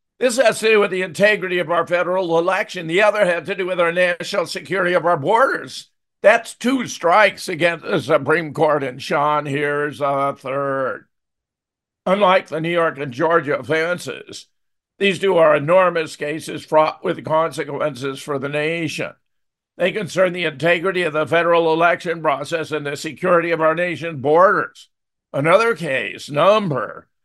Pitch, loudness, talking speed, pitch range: 165 Hz, -18 LUFS, 160 wpm, 155-185 Hz